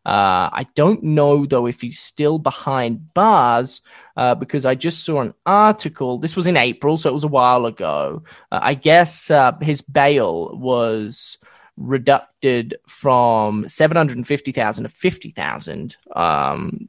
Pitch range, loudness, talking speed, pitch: 125-160 Hz, -17 LUFS, 165 wpm, 140 Hz